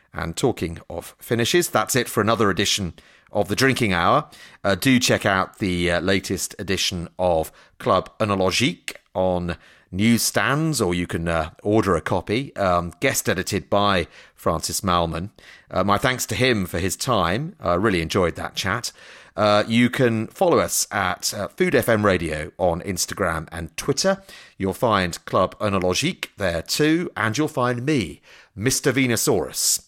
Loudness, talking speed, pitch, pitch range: -21 LUFS, 160 wpm, 100 Hz, 90-120 Hz